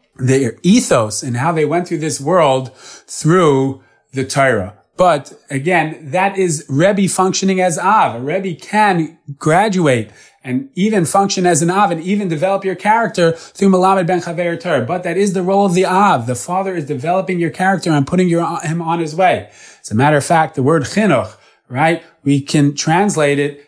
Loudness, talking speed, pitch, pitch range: -15 LUFS, 190 wpm, 170 Hz, 145-185 Hz